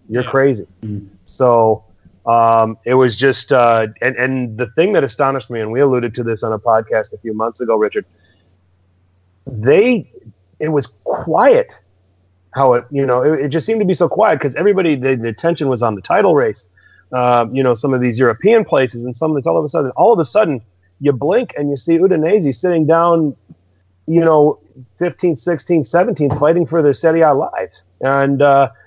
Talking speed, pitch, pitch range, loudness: 195 wpm, 130 Hz, 110-160 Hz, -15 LUFS